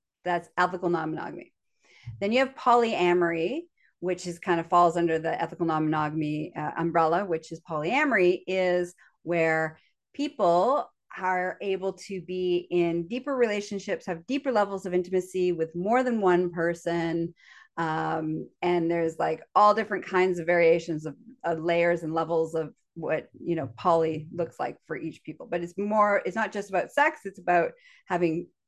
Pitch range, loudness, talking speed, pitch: 165-195 Hz, -27 LUFS, 165 wpm, 175 Hz